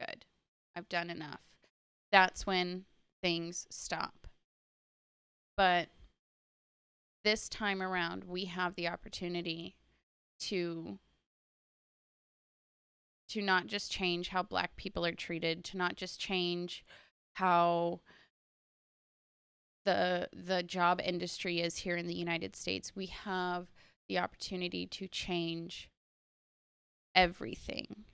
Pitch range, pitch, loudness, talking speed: 170-185 Hz, 175 Hz, -35 LUFS, 100 wpm